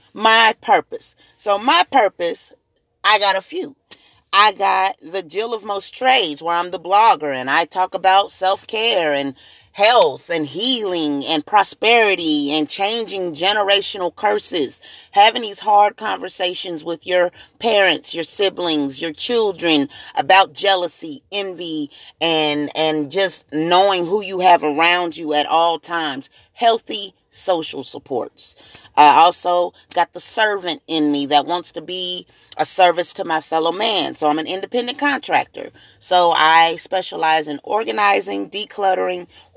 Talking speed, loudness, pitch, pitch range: 140 wpm, -17 LUFS, 180 Hz, 160-200 Hz